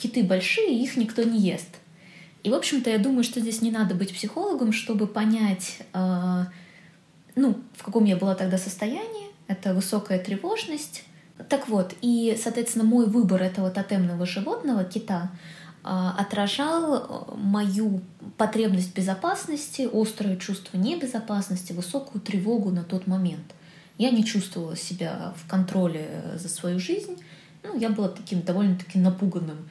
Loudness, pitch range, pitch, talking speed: -26 LUFS, 180-230 Hz, 200 Hz, 135 wpm